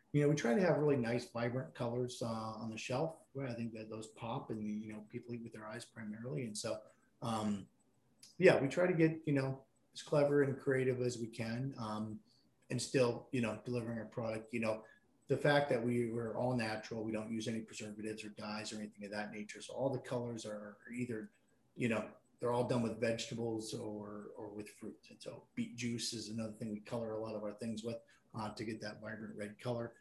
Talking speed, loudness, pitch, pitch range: 230 wpm, -39 LUFS, 115 Hz, 110-125 Hz